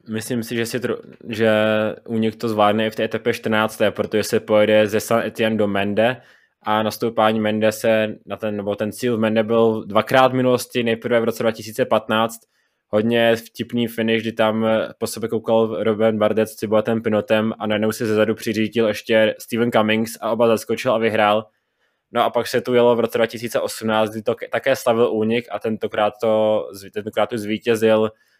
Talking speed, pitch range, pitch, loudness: 180 wpm, 110-115 Hz, 110 Hz, -20 LUFS